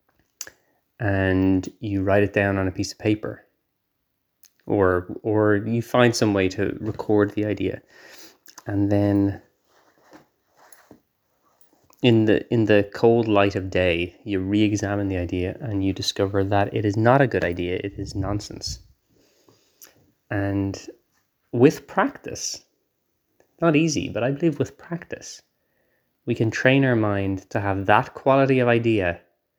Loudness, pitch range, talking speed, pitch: -22 LUFS, 95-115 Hz, 140 wpm, 100 Hz